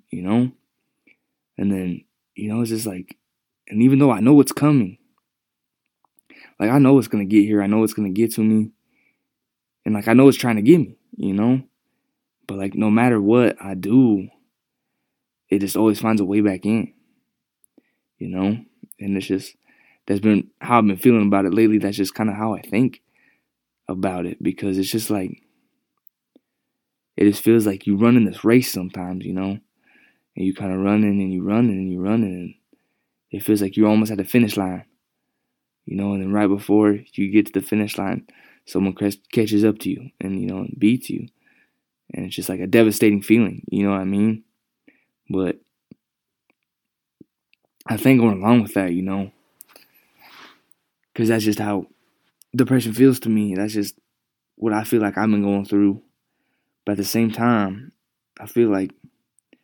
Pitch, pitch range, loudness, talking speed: 105 Hz, 100-115 Hz, -19 LUFS, 185 wpm